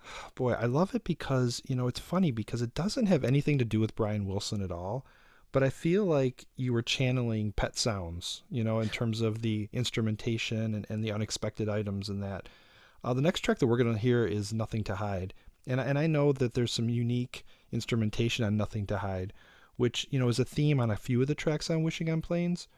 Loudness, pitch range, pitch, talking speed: -31 LUFS, 110-135 Hz, 120 Hz, 225 wpm